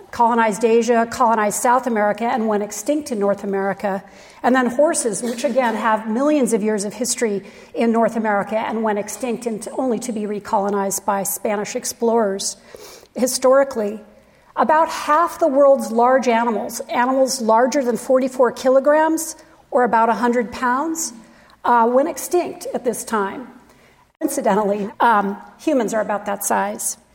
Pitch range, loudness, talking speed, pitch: 210-265 Hz, -19 LUFS, 145 wpm, 235 Hz